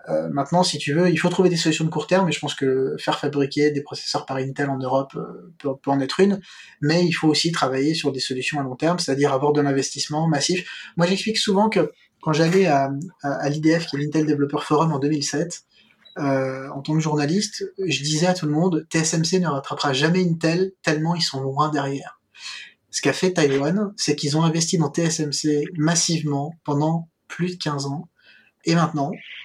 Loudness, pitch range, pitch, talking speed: -22 LUFS, 140-175 Hz, 155 Hz, 210 wpm